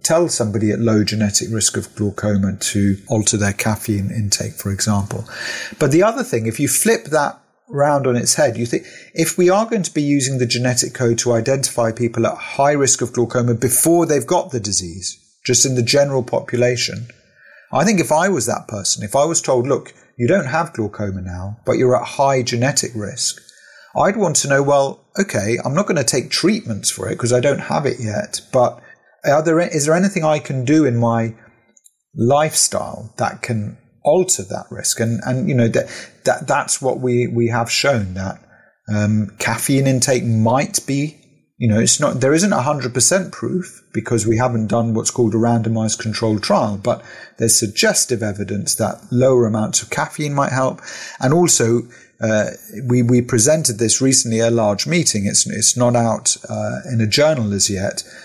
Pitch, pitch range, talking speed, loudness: 120 Hz, 110-140 Hz, 195 wpm, -17 LUFS